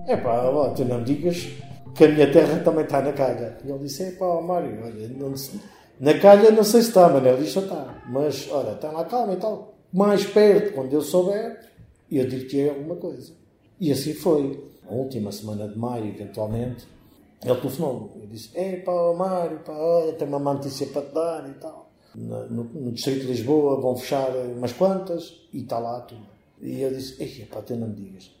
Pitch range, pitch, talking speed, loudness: 120-170 Hz, 140 Hz, 200 wpm, -22 LUFS